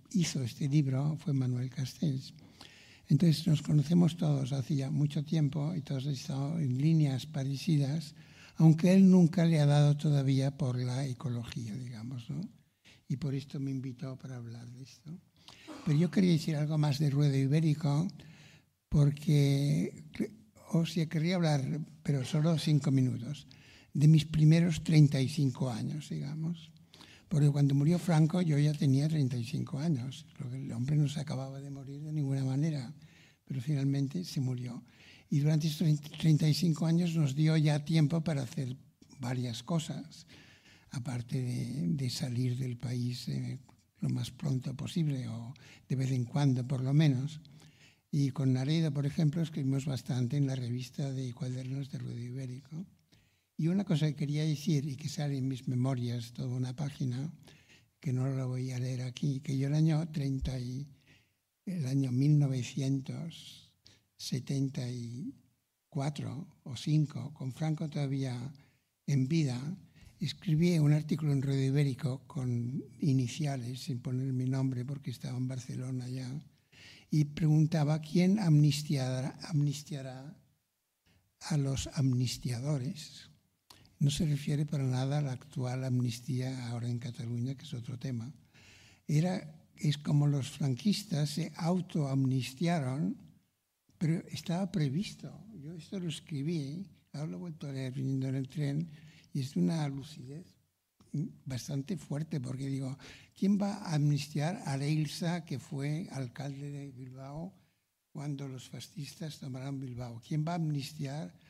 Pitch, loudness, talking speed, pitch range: 145 Hz, -32 LUFS, 140 wpm, 130-155 Hz